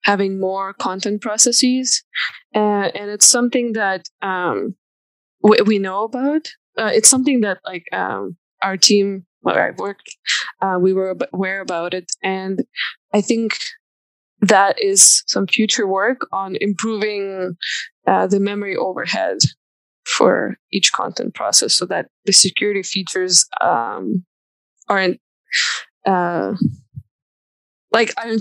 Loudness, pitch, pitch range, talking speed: -17 LUFS, 200 Hz, 190-225 Hz, 125 wpm